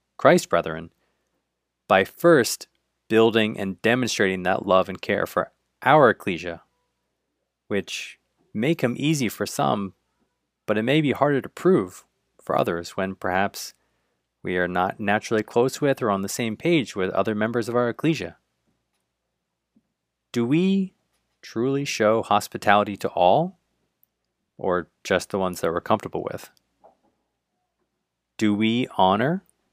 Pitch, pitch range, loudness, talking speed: 110 Hz, 95-125 Hz, -23 LUFS, 135 wpm